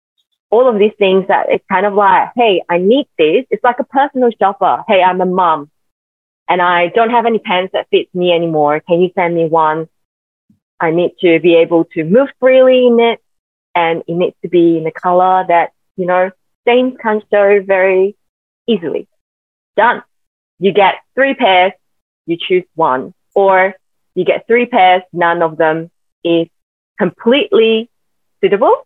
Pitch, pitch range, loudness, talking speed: 185 Hz, 170-235 Hz, -12 LUFS, 170 wpm